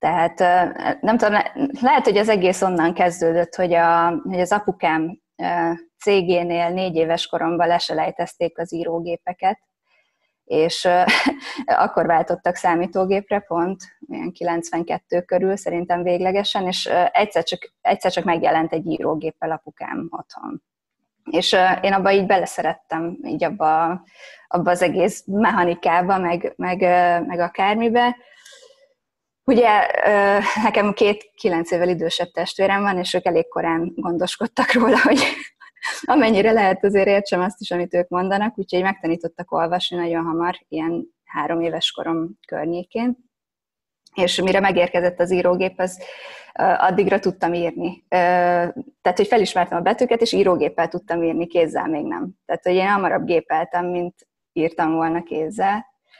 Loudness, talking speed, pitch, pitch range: -20 LUFS, 130 wpm, 180 Hz, 170-200 Hz